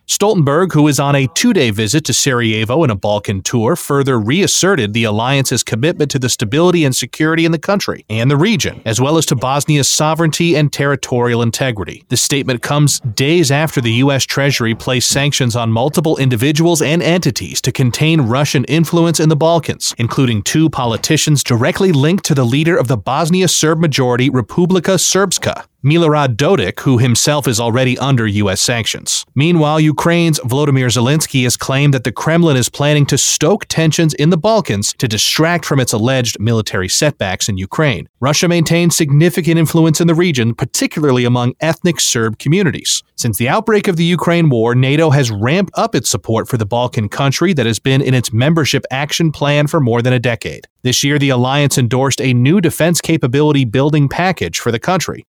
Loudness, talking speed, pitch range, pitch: -13 LUFS, 180 wpm, 125-160 Hz, 140 Hz